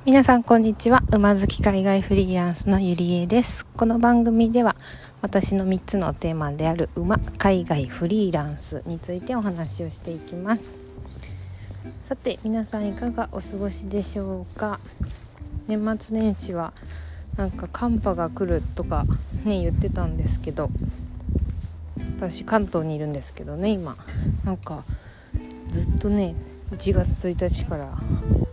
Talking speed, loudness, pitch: 270 characters per minute, -24 LUFS, 170 Hz